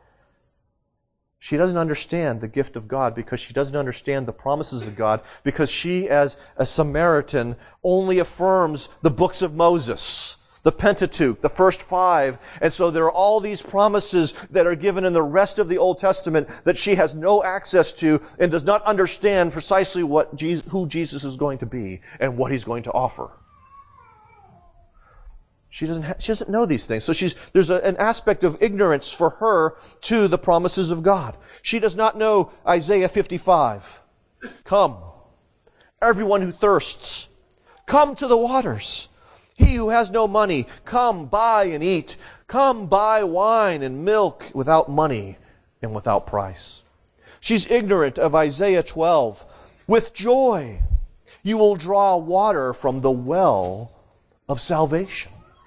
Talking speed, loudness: 155 wpm, -20 LUFS